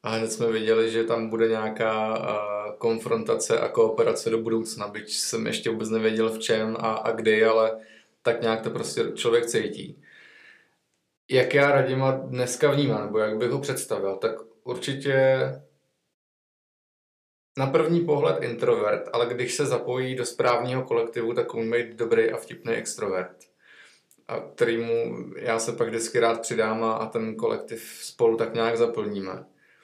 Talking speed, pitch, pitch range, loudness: 150 wpm, 115 Hz, 110-140 Hz, -25 LUFS